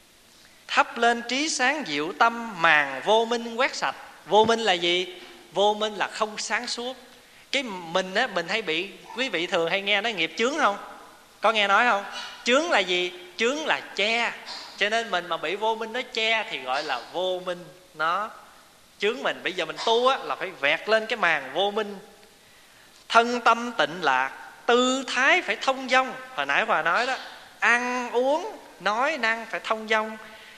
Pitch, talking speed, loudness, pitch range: 220 Hz, 190 wpm, -24 LUFS, 190-240 Hz